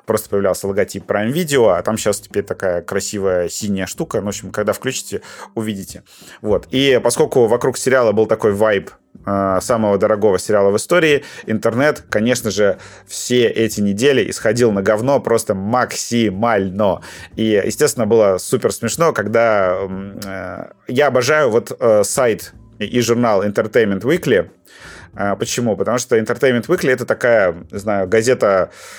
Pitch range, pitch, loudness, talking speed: 100-120 Hz, 110 Hz, -16 LUFS, 145 wpm